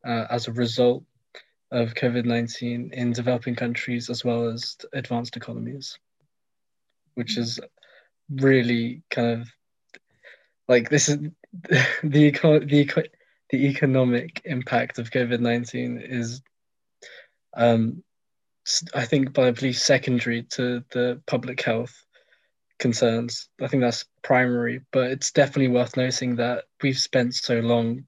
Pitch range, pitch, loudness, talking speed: 120-135 Hz, 125 Hz, -23 LUFS, 120 wpm